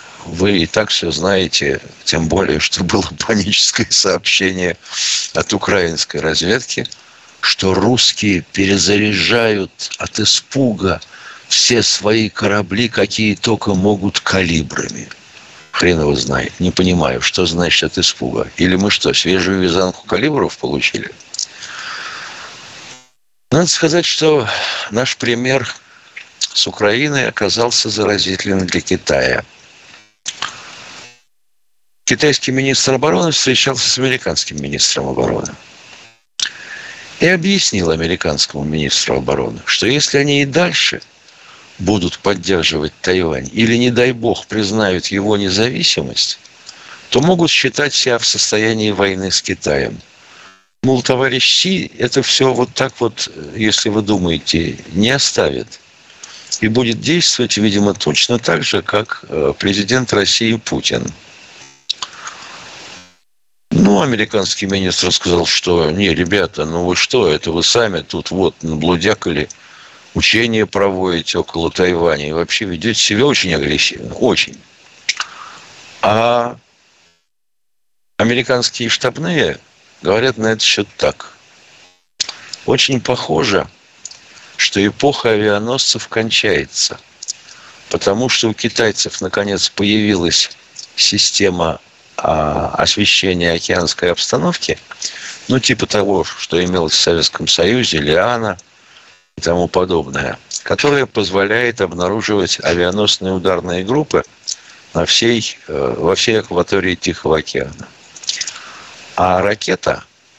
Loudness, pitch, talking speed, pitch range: -14 LUFS, 105 Hz, 105 wpm, 90-120 Hz